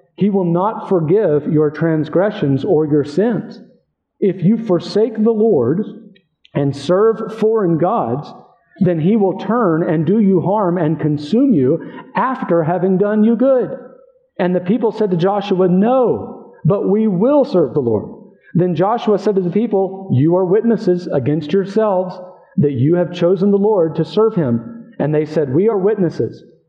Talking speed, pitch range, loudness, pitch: 165 wpm, 170-215 Hz, -16 LUFS, 190 Hz